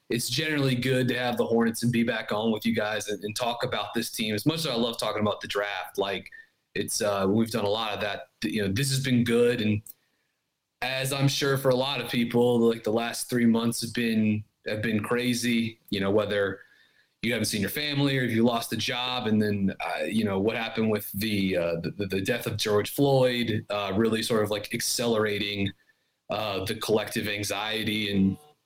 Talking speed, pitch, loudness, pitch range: 220 wpm, 115 Hz, -27 LUFS, 105-125 Hz